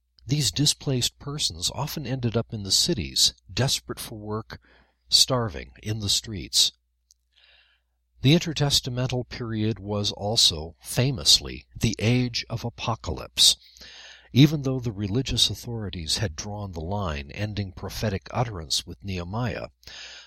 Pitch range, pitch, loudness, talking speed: 85-125 Hz, 105 Hz, -24 LUFS, 120 wpm